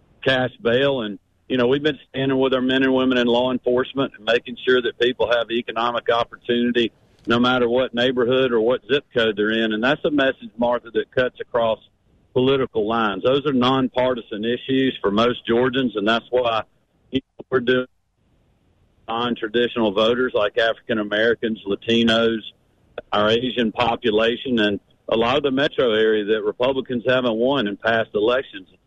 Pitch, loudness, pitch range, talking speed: 120 Hz, -20 LUFS, 115-130 Hz, 165 wpm